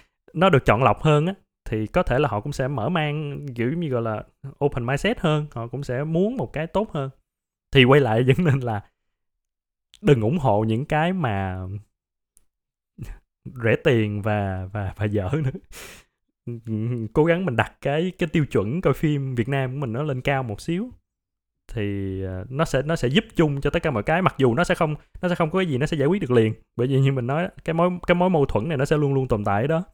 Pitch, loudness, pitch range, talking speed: 135 Hz, -23 LUFS, 110-160 Hz, 230 wpm